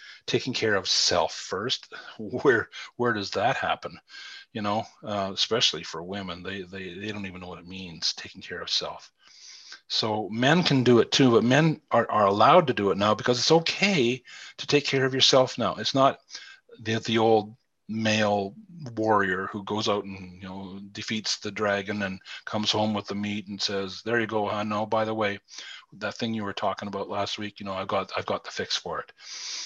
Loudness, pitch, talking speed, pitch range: -25 LUFS, 105 Hz, 210 wpm, 100-125 Hz